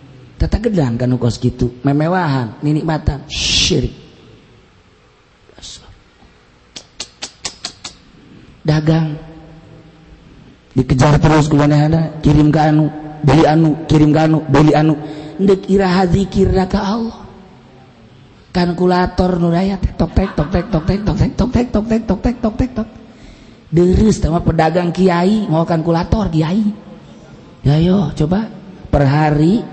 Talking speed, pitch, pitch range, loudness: 115 wpm, 160 Hz, 150-185 Hz, -14 LUFS